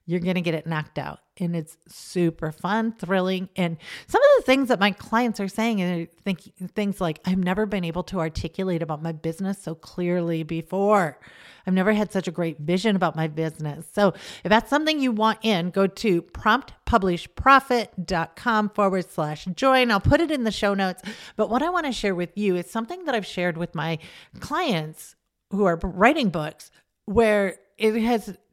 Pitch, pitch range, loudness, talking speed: 190 Hz, 170-220 Hz, -24 LUFS, 190 wpm